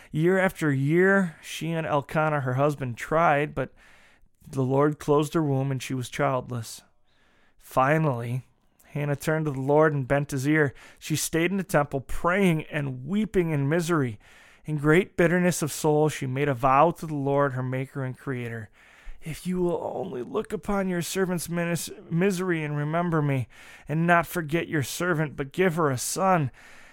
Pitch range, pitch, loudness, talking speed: 140-170 Hz, 150 Hz, -25 LUFS, 170 wpm